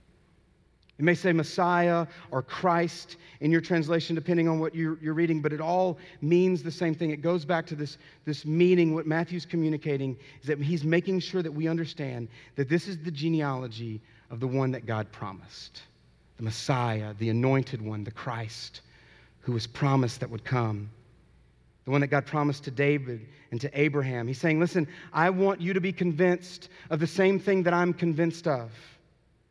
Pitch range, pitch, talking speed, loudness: 130-170 Hz, 155 Hz, 185 wpm, -28 LUFS